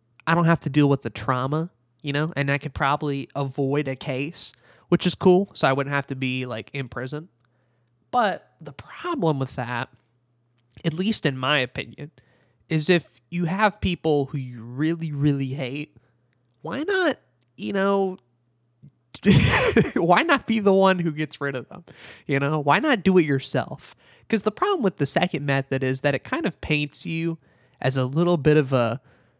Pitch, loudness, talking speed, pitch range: 140 Hz, -23 LUFS, 185 wpm, 125-165 Hz